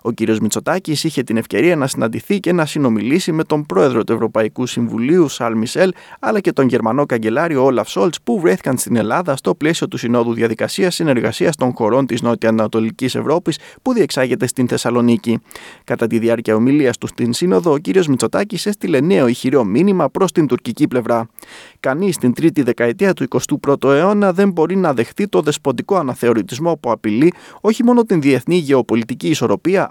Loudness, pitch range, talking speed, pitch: -16 LUFS, 115-175 Hz, 175 wpm, 135 Hz